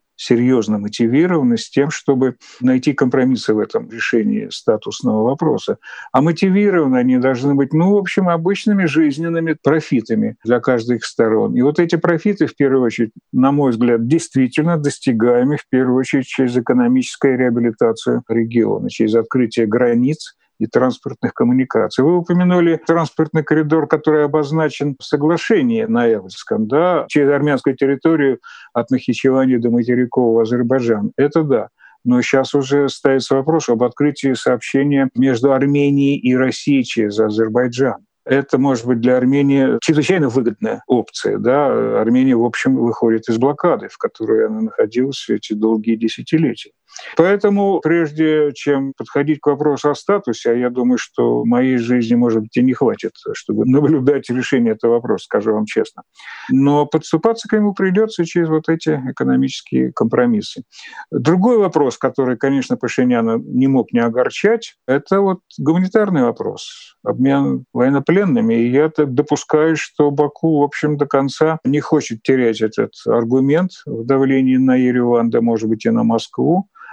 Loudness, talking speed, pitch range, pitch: -16 LUFS, 145 wpm, 125-160 Hz, 140 Hz